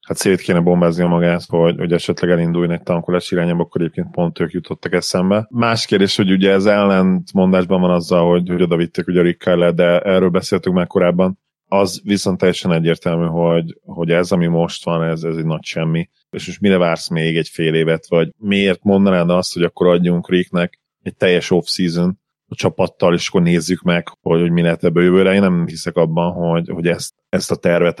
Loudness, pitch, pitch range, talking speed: -16 LUFS, 85 Hz, 85-95 Hz, 205 wpm